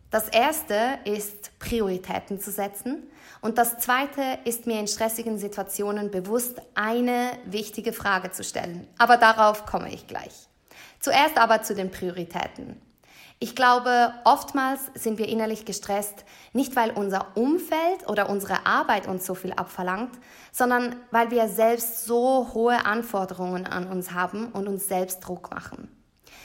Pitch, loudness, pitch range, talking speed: 220 Hz, -25 LUFS, 200-240 Hz, 145 wpm